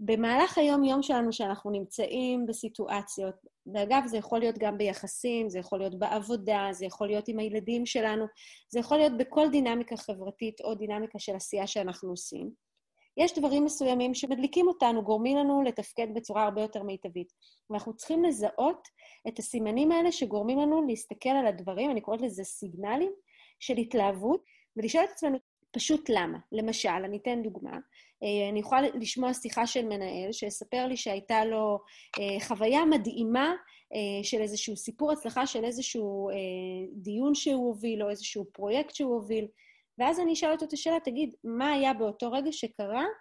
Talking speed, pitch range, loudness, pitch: 155 wpm, 210-270 Hz, -30 LUFS, 230 Hz